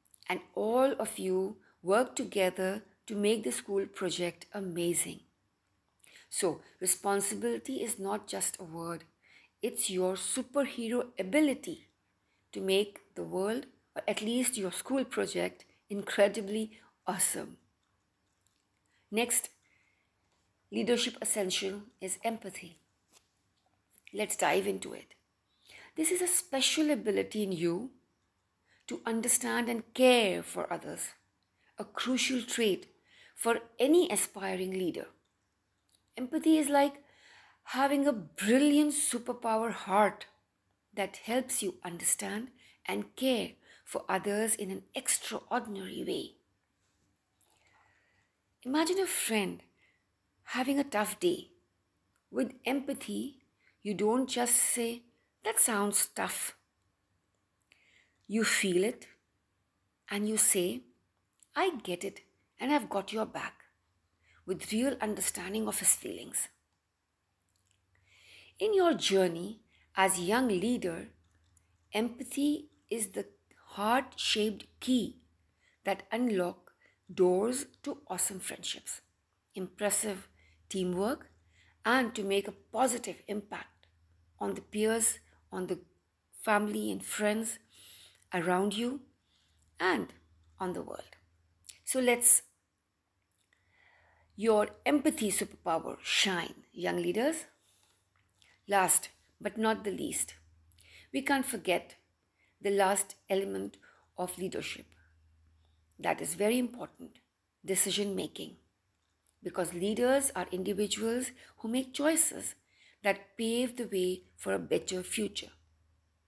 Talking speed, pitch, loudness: 105 wpm, 200 Hz, -31 LUFS